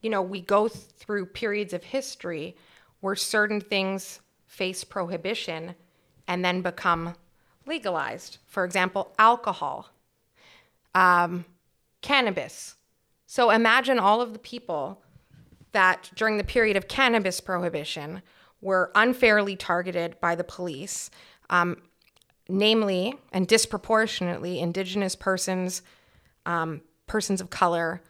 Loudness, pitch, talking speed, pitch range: -25 LUFS, 190 Hz, 110 wpm, 175-210 Hz